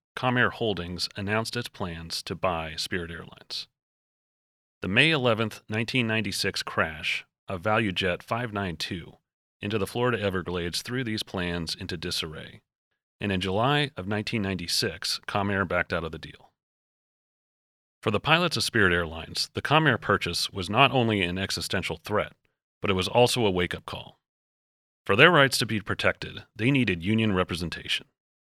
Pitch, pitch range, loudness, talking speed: 100 Hz, 90-115 Hz, -26 LUFS, 150 wpm